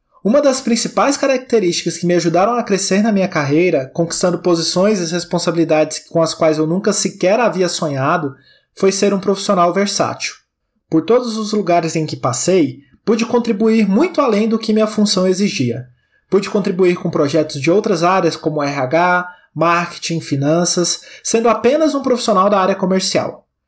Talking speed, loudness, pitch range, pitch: 160 wpm, -15 LUFS, 165-210 Hz, 180 Hz